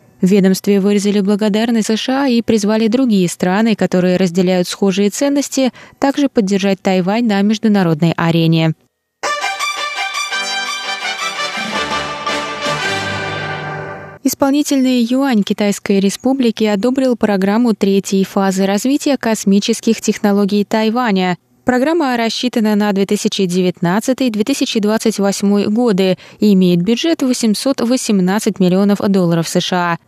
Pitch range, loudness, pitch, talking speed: 195-240 Hz, -15 LUFS, 210 Hz, 85 wpm